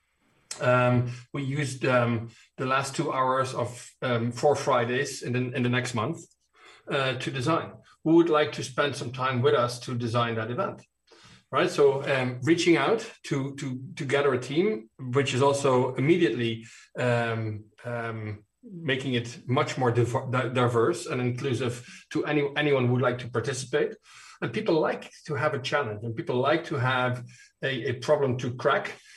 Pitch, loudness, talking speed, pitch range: 130 Hz, -27 LUFS, 175 wpm, 120-145 Hz